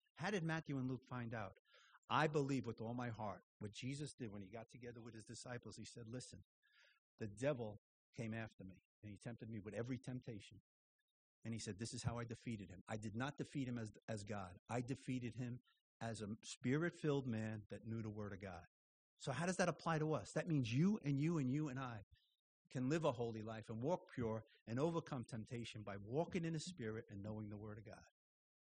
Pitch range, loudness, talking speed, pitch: 110-140 Hz, -46 LUFS, 225 wpm, 120 Hz